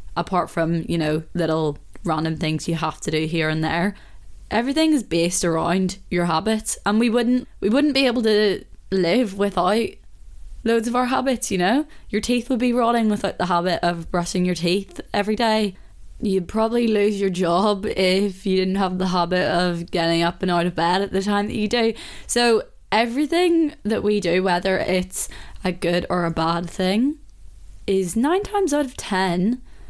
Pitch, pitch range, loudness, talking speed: 190 Hz, 175-230 Hz, -21 LUFS, 185 wpm